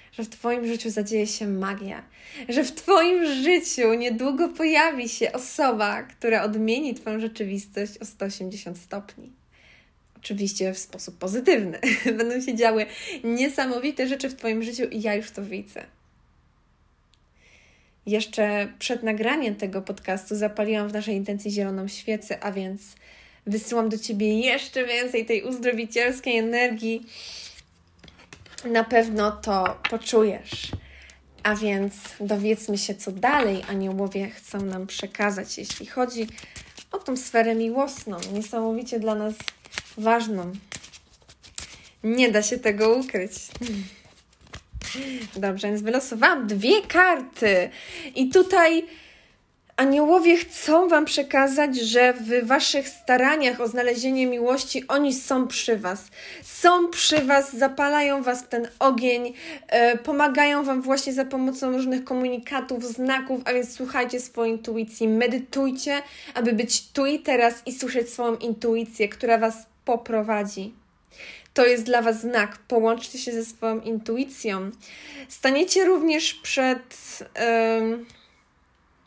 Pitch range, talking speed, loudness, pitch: 210-265 Hz, 120 wpm, -23 LUFS, 235 Hz